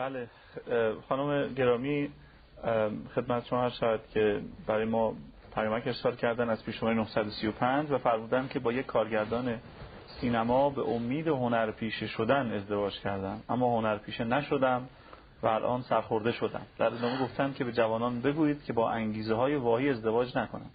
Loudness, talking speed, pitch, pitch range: -30 LUFS, 145 wpm, 120 Hz, 110-130 Hz